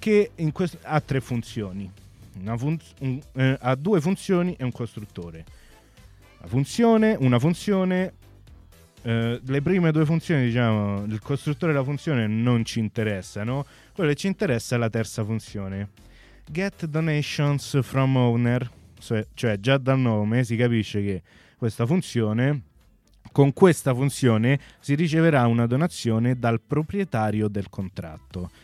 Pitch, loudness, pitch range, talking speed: 120 Hz, -24 LUFS, 110-150 Hz, 140 wpm